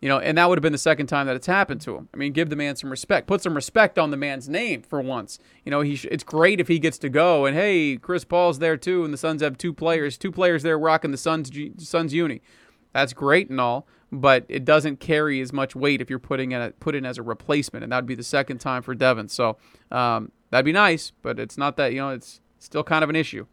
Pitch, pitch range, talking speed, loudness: 150 Hz, 135-165 Hz, 280 wpm, -22 LUFS